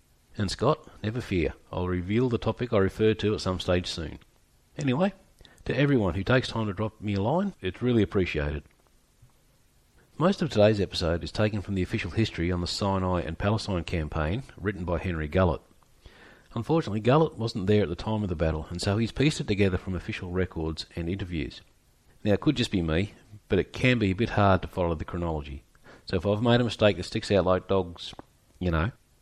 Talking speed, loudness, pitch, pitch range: 205 wpm, -27 LUFS, 100 Hz, 90-115 Hz